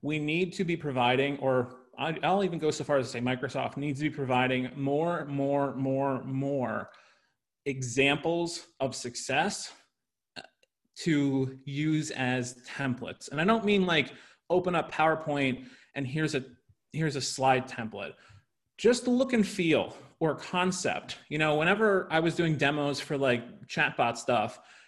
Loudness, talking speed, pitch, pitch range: -29 LUFS, 150 wpm, 140 Hz, 130-165 Hz